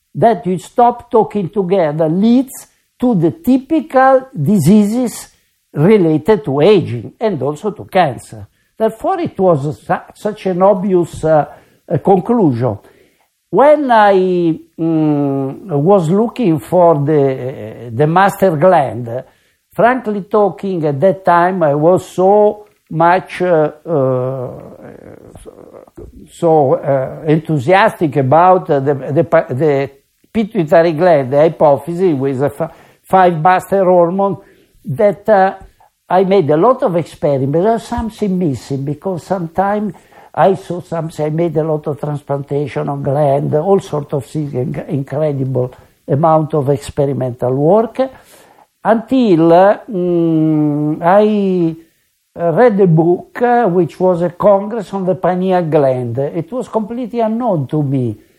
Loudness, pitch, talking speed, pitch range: -13 LUFS, 170 Hz, 125 wpm, 150-200 Hz